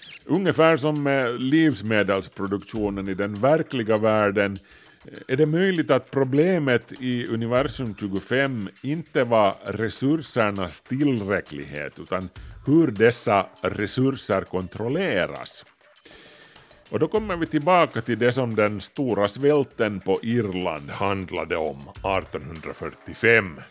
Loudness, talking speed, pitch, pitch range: -23 LUFS, 105 wpm, 115 Hz, 100-140 Hz